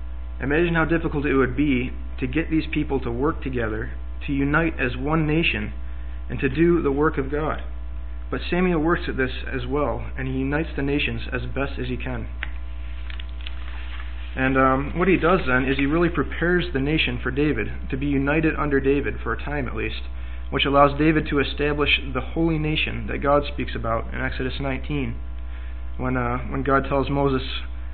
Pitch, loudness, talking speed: 135 Hz, -23 LUFS, 185 wpm